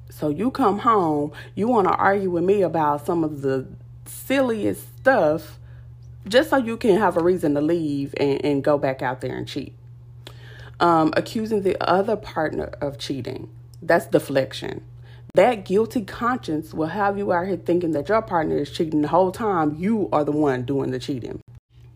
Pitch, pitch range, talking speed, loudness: 150 Hz, 125-185 Hz, 180 wpm, -22 LUFS